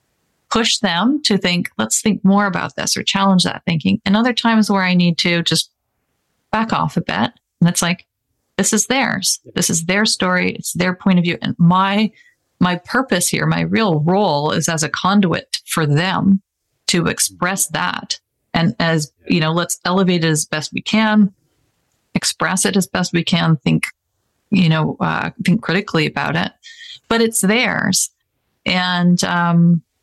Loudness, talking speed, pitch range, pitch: -17 LUFS, 175 wpm, 165-205 Hz, 180 Hz